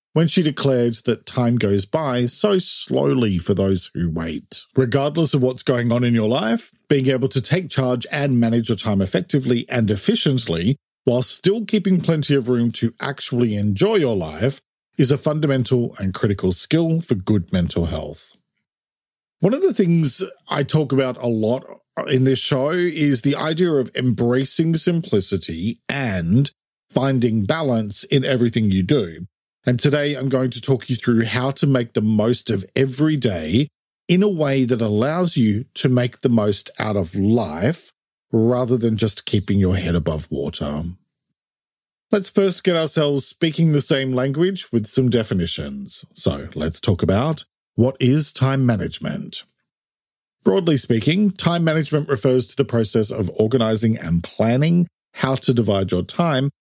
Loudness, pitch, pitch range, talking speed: -19 LUFS, 125 Hz, 110-150 Hz, 160 wpm